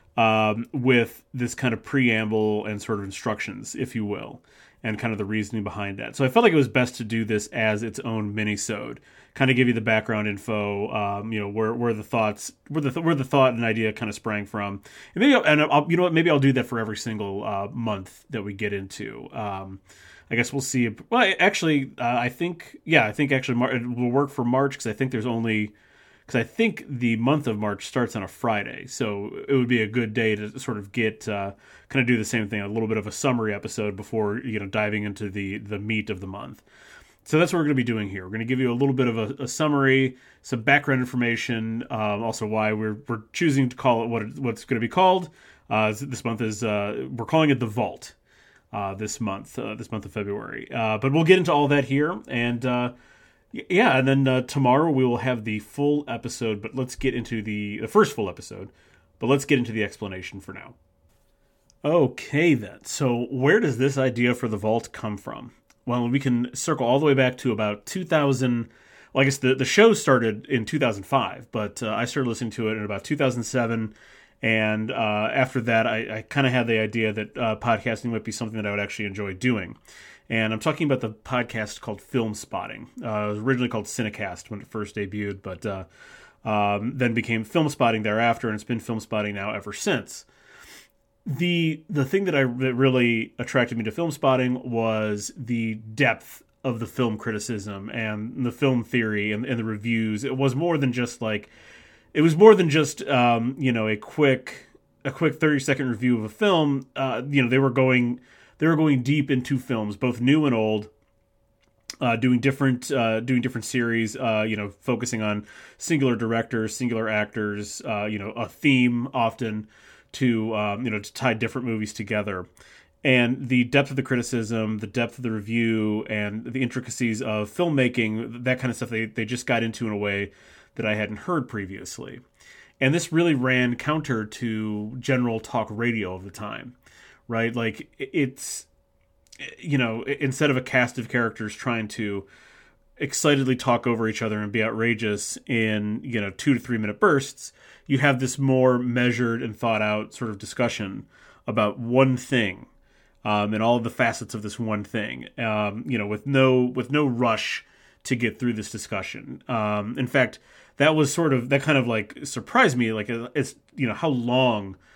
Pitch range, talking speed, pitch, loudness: 110-130 Hz, 210 wpm, 115 Hz, -24 LUFS